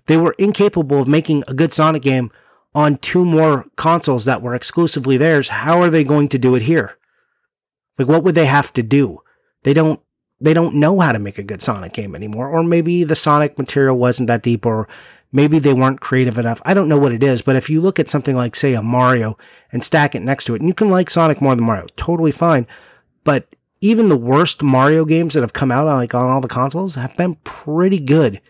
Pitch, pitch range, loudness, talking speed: 145 Hz, 125-160 Hz, -15 LUFS, 230 wpm